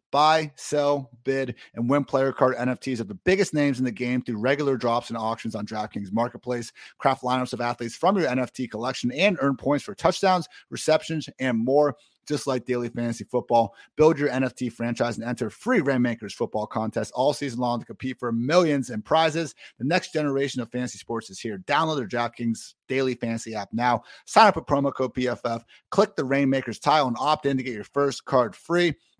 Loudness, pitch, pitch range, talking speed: -25 LUFS, 130 Hz, 120-145 Hz, 200 wpm